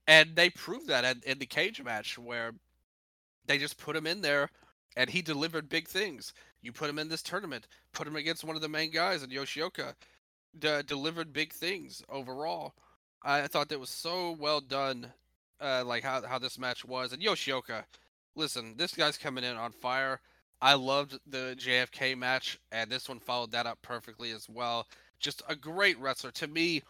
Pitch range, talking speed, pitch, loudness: 125-155 Hz, 190 wpm, 135 Hz, -32 LUFS